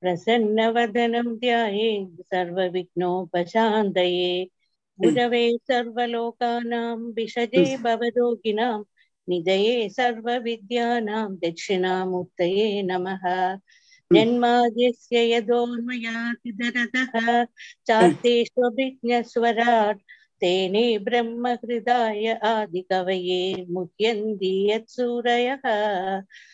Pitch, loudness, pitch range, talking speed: 230 Hz, -23 LUFS, 190-240 Hz, 60 wpm